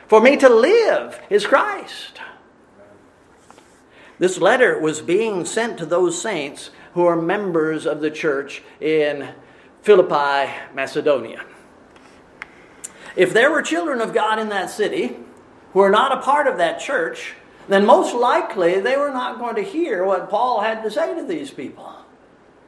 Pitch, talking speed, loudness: 205 Hz, 150 wpm, -18 LUFS